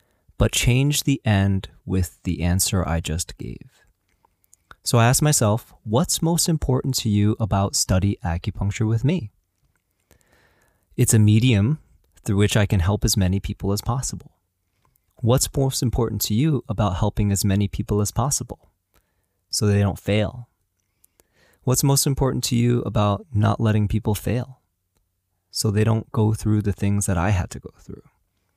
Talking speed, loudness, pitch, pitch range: 160 wpm, -21 LUFS, 105 Hz, 95-120 Hz